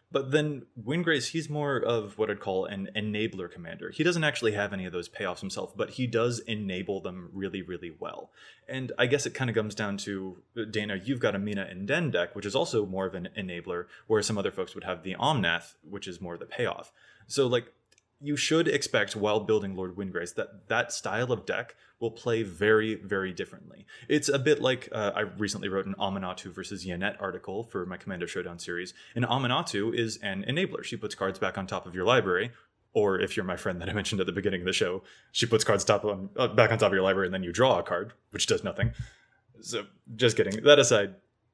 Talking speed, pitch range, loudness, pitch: 225 wpm, 95-120 Hz, -29 LUFS, 105 Hz